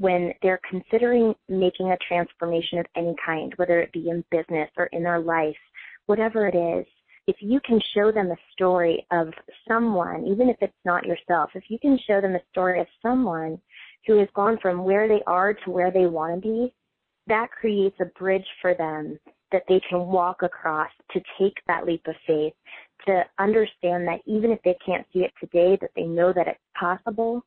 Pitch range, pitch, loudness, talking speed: 170-205 Hz, 185 Hz, -24 LUFS, 195 wpm